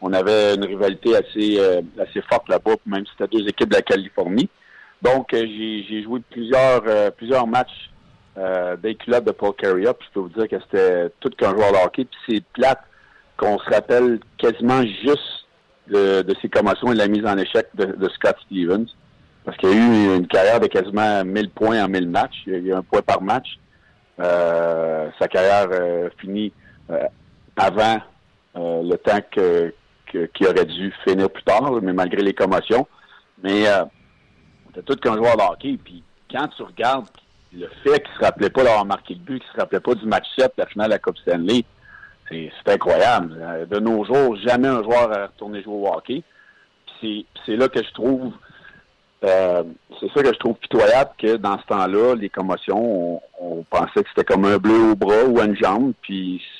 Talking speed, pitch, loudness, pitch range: 210 wpm, 105 Hz, -19 LUFS, 95-115 Hz